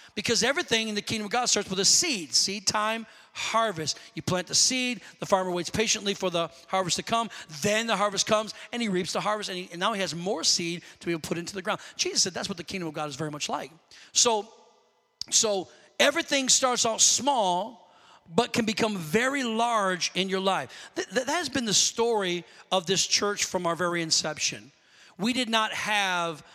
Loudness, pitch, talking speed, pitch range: -26 LUFS, 205 Hz, 215 wpm, 180-230 Hz